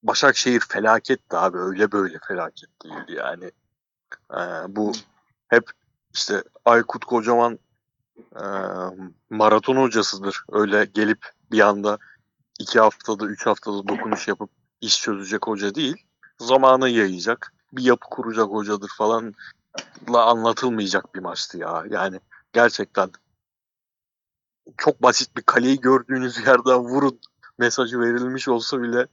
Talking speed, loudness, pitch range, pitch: 115 wpm, -21 LUFS, 105-125 Hz, 115 Hz